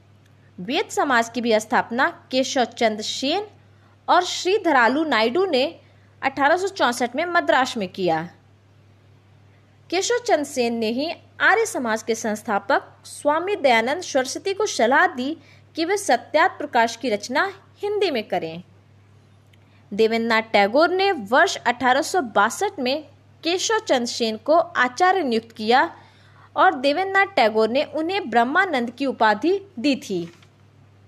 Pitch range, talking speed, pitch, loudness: 215-335 Hz, 125 wpm, 255 Hz, -21 LUFS